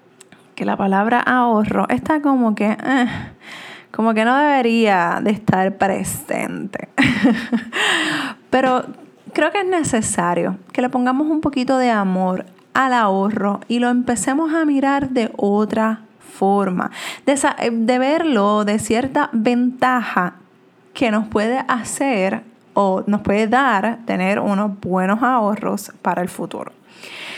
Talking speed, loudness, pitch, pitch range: 130 wpm, -18 LUFS, 235 Hz, 205-260 Hz